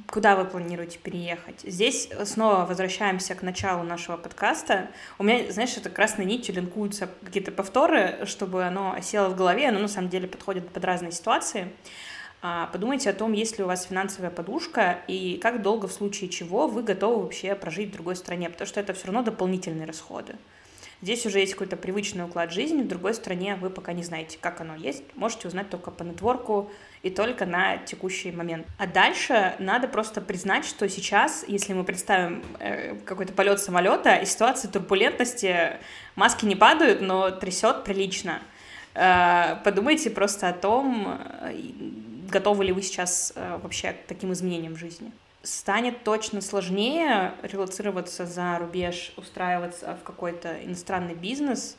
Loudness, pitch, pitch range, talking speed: -26 LUFS, 195 Hz, 180-215 Hz, 160 wpm